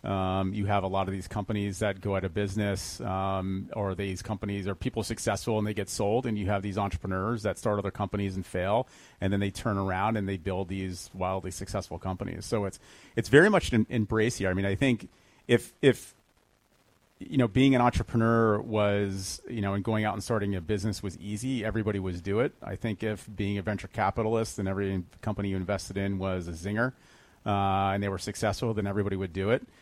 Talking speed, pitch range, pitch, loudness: 215 wpm, 95-110 Hz, 100 Hz, -29 LUFS